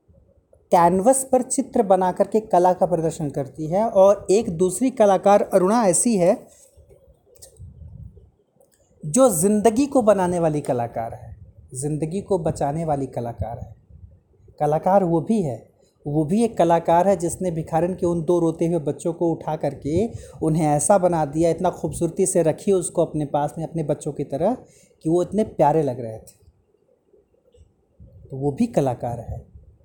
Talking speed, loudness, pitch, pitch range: 160 wpm, -21 LUFS, 170 Hz, 145-195 Hz